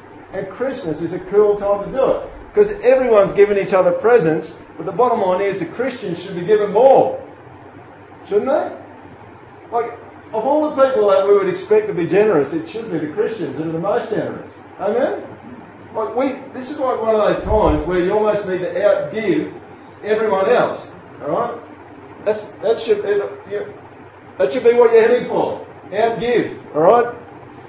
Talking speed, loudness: 185 wpm, -17 LUFS